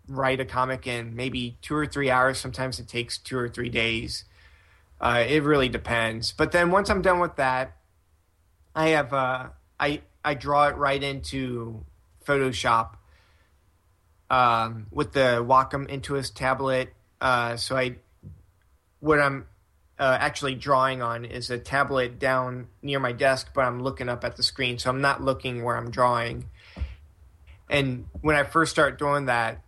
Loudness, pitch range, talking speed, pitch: -25 LUFS, 110-135 Hz, 160 wpm, 125 Hz